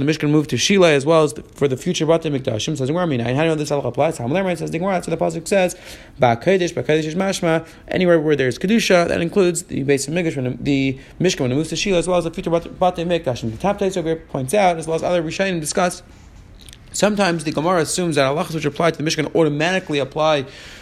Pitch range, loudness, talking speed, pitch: 140-180 Hz, -19 LUFS, 210 wpm, 160 Hz